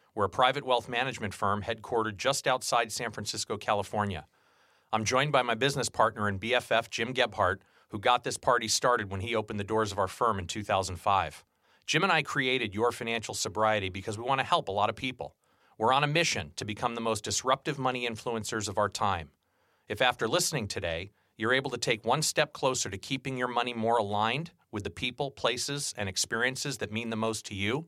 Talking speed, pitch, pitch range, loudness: 205 wpm, 115 Hz, 105-130 Hz, -29 LUFS